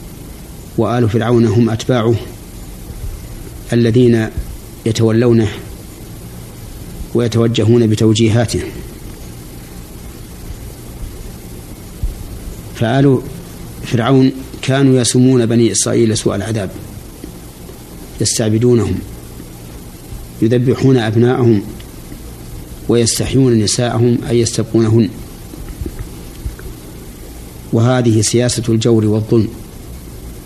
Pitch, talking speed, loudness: 115 Hz, 55 wpm, -13 LUFS